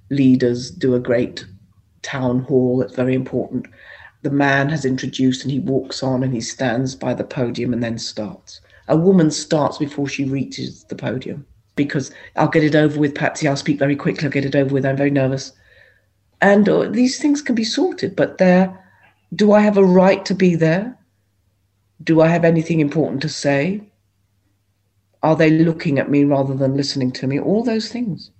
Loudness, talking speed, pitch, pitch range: -18 LUFS, 190 wpm, 140 Hz, 125-160 Hz